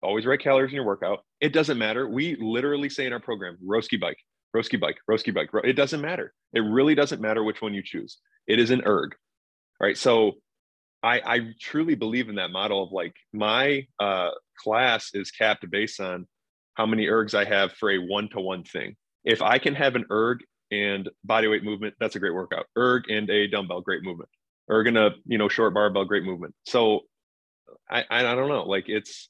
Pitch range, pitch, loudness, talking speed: 105-135 Hz, 110 Hz, -25 LUFS, 205 wpm